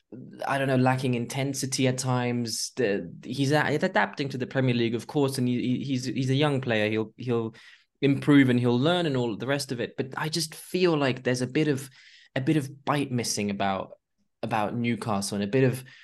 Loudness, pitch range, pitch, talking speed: -26 LUFS, 120-140 Hz, 130 Hz, 200 wpm